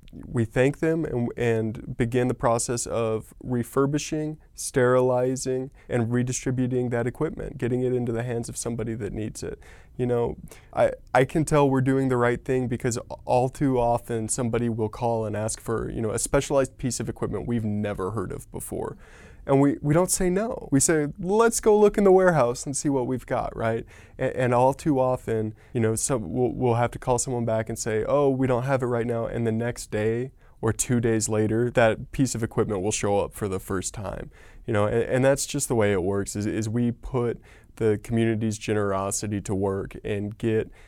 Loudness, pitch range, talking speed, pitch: -25 LUFS, 110-130 Hz, 210 wpm, 120 Hz